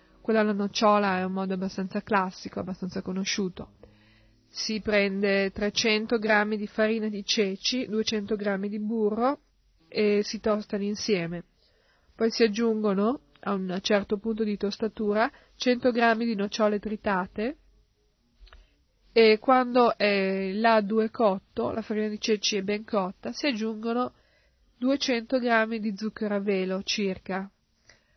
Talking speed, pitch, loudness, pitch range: 135 wpm, 215 Hz, -27 LUFS, 200-225 Hz